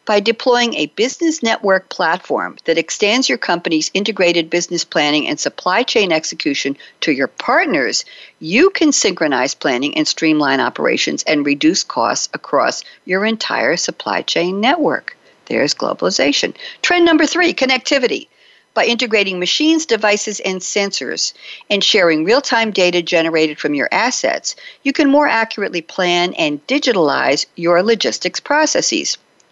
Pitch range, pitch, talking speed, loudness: 175-285 Hz, 210 Hz, 135 wpm, -15 LUFS